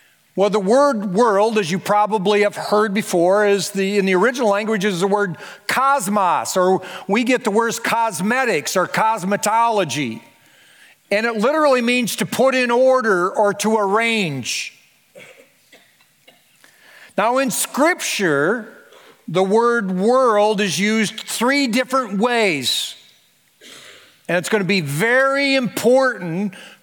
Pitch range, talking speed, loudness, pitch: 200-245 Hz, 125 wpm, -18 LUFS, 215 Hz